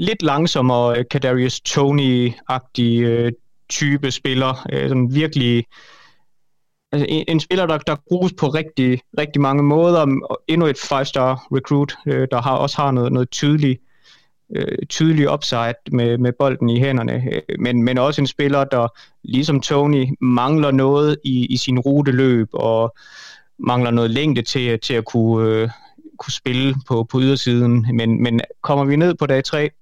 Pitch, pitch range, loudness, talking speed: 135 Hz, 120-145 Hz, -18 LUFS, 165 wpm